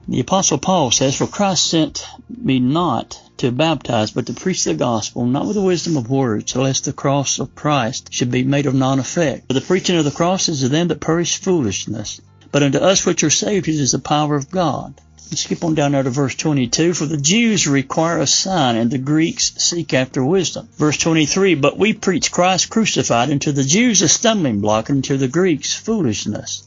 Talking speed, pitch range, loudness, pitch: 215 wpm, 130-175 Hz, -17 LUFS, 150 Hz